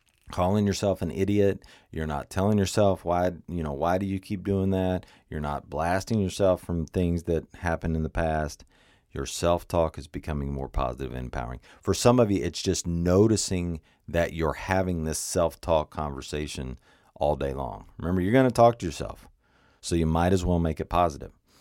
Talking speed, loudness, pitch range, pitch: 185 wpm, -27 LUFS, 75-95 Hz, 85 Hz